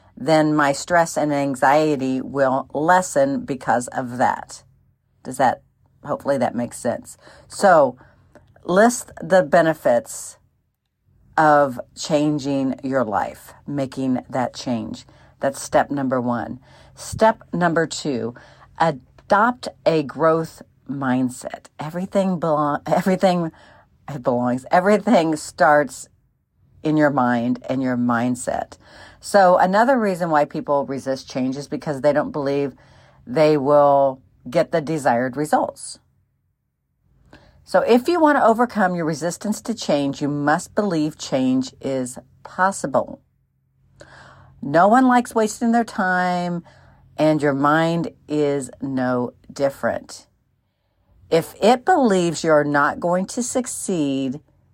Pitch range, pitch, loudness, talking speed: 135-180 Hz, 150 Hz, -20 LUFS, 115 wpm